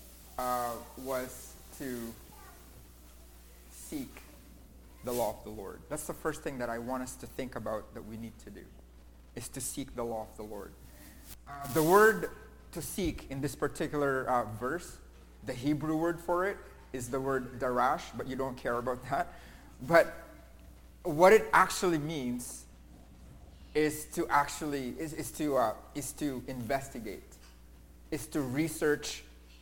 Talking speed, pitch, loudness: 155 wpm, 125 Hz, -32 LUFS